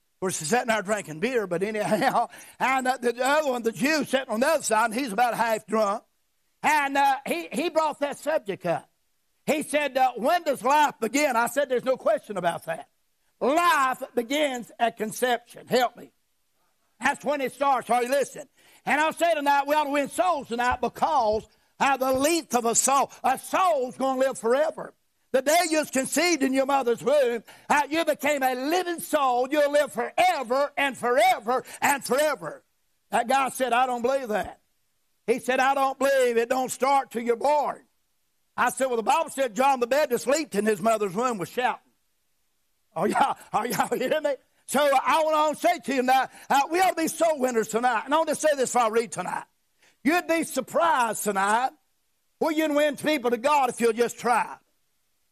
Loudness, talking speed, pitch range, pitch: -24 LUFS, 205 wpm, 240-295 Hz, 265 Hz